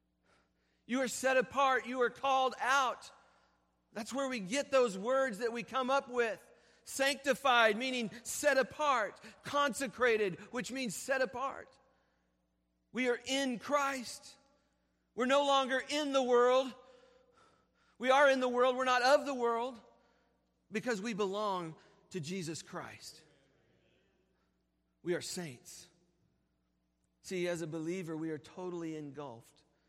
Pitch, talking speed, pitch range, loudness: 240 Hz, 130 wpm, 170-265 Hz, -33 LUFS